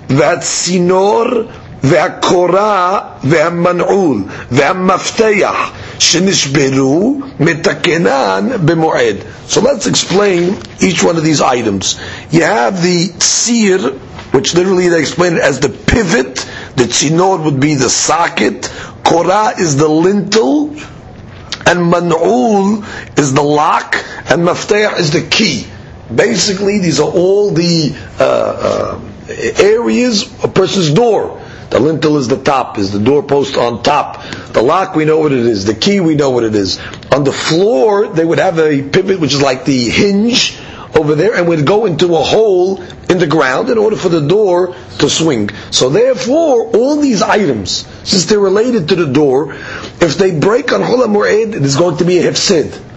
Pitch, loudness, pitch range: 175 Hz, -11 LUFS, 150-200 Hz